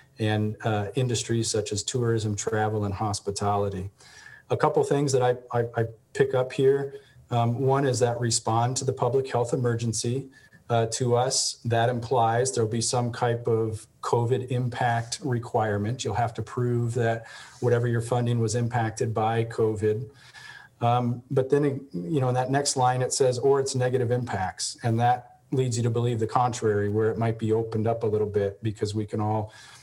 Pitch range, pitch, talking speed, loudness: 110-125 Hz, 120 Hz, 185 wpm, -26 LUFS